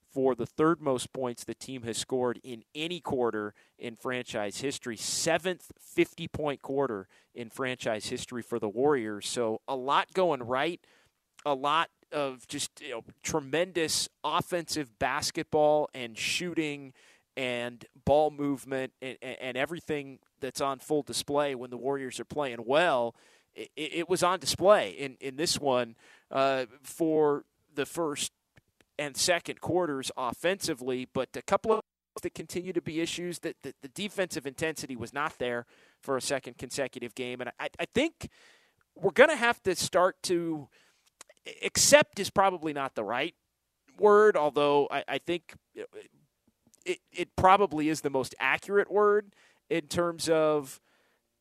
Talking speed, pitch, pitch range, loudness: 155 wpm, 145 Hz, 130-170 Hz, -29 LUFS